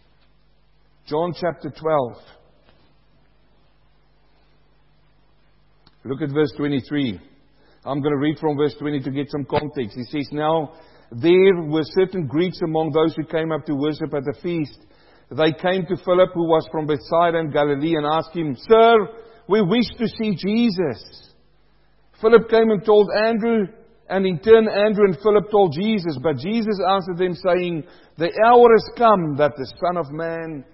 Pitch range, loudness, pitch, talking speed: 150-200 Hz, -19 LUFS, 165 Hz, 160 wpm